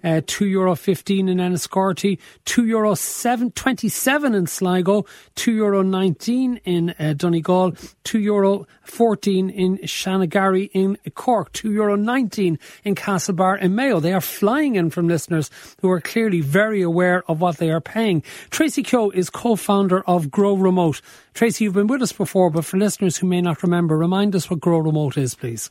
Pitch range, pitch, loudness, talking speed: 175-210 Hz, 190 Hz, -20 LUFS, 175 wpm